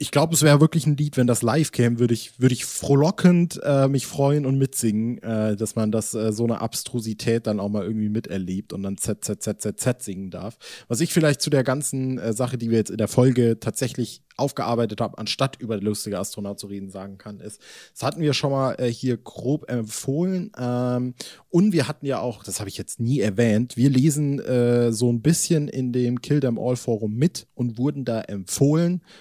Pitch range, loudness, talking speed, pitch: 110-140 Hz, -23 LUFS, 210 wpm, 125 Hz